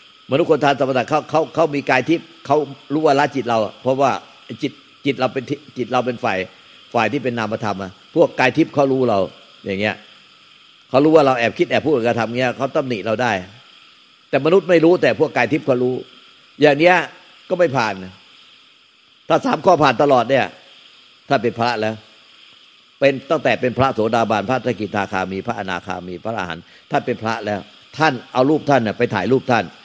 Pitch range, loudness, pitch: 110-140 Hz, -18 LUFS, 125 Hz